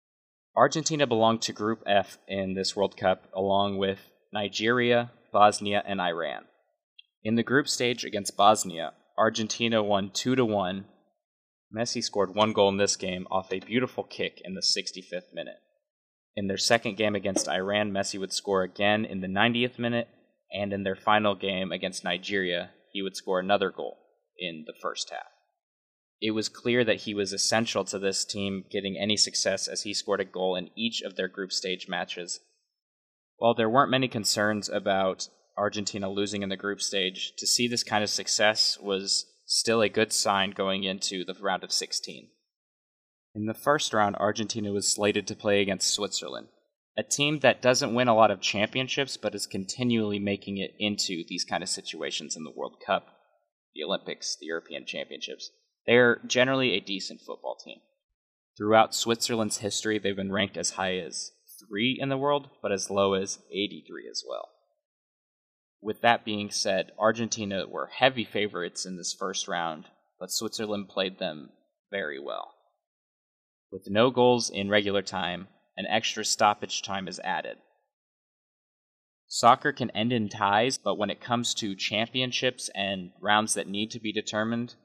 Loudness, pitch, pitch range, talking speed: -27 LUFS, 105 Hz, 95-115 Hz, 170 wpm